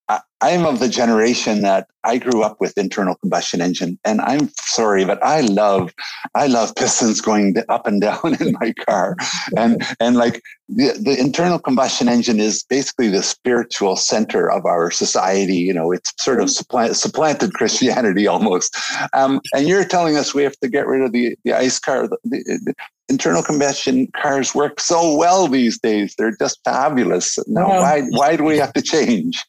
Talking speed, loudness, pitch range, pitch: 185 wpm, -17 LUFS, 115-155 Hz, 135 Hz